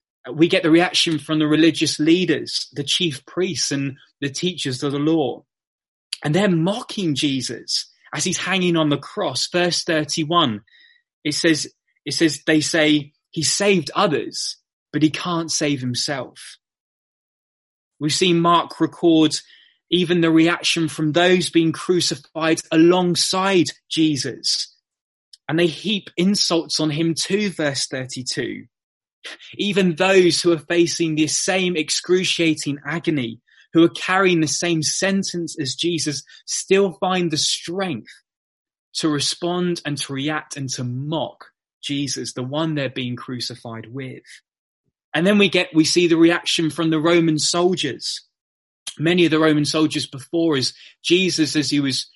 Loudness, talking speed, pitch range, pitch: -19 LUFS, 145 wpm, 145-175 Hz, 160 Hz